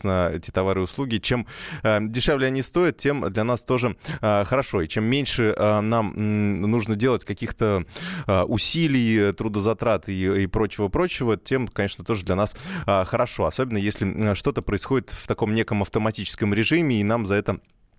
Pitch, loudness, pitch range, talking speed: 110 Hz, -23 LUFS, 100-125 Hz, 175 wpm